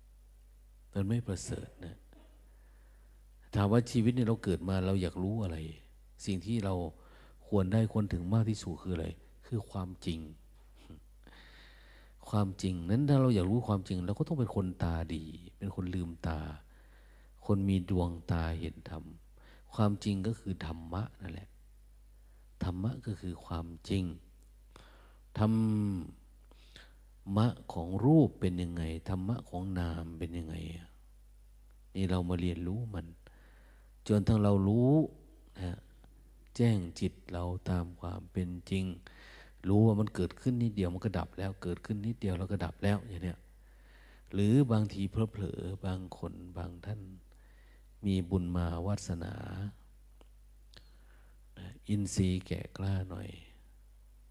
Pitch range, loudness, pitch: 80-100 Hz, -34 LUFS, 90 Hz